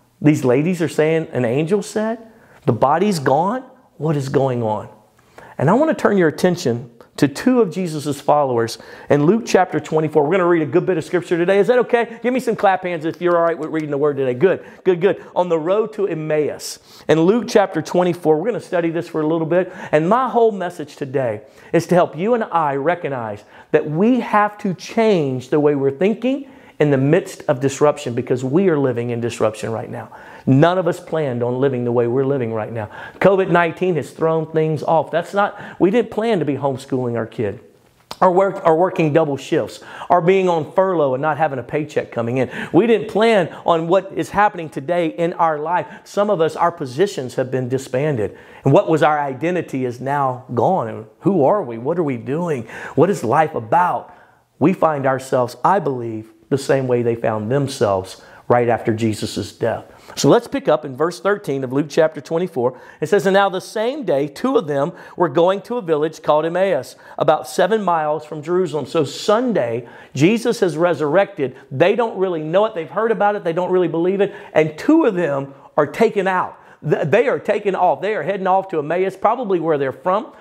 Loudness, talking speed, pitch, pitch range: -18 LUFS, 210 wpm, 165 Hz, 140-195 Hz